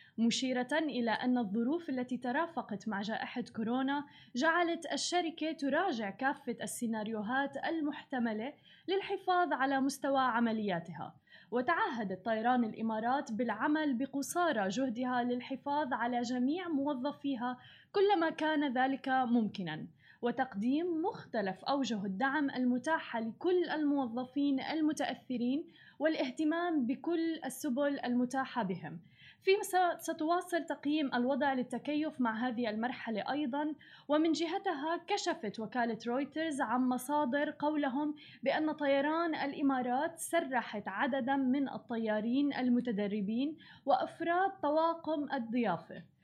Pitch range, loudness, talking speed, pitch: 240-305 Hz, -34 LUFS, 95 wpm, 270 Hz